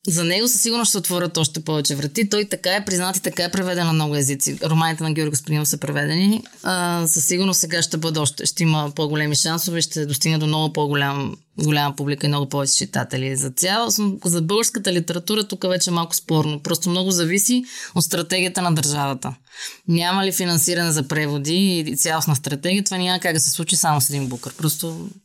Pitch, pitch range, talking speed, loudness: 170 Hz, 150-185 Hz, 195 wpm, -19 LUFS